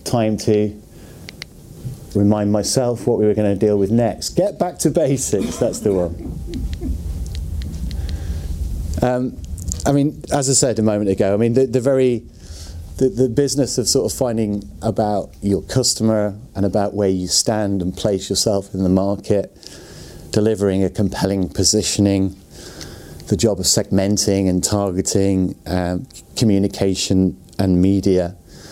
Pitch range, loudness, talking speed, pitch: 90-110 Hz, -18 LUFS, 140 wpm, 100 Hz